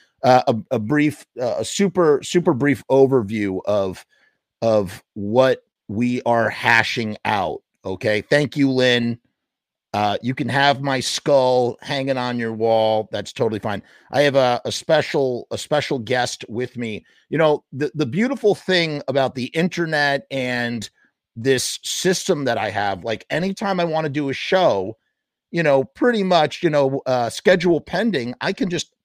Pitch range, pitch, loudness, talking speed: 115-150 Hz, 130 Hz, -20 LUFS, 165 wpm